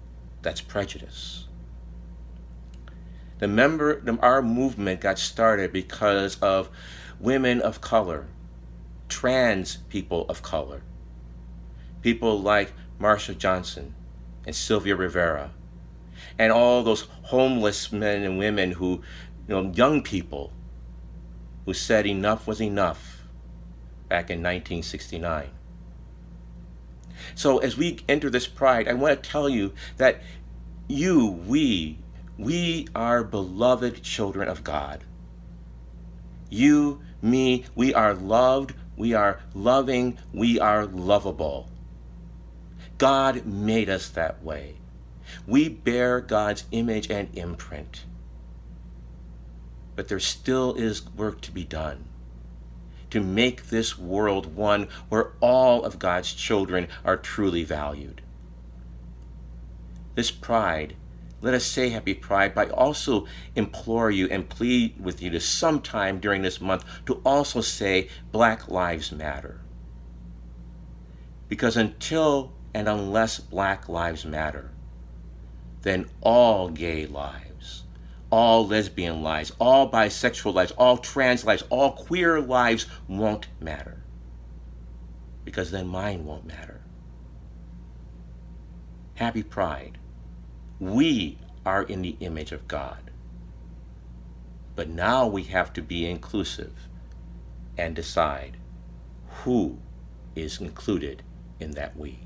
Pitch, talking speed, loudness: 80 Hz, 110 wpm, -24 LUFS